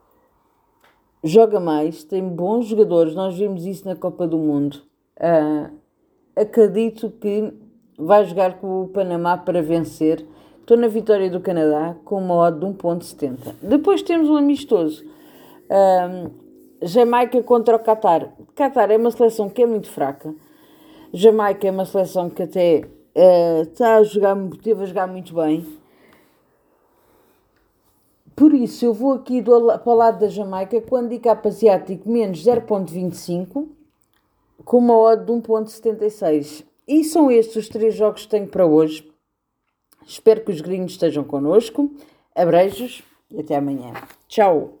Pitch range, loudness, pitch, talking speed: 175-235 Hz, -18 LUFS, 205 Hz, 140 wpm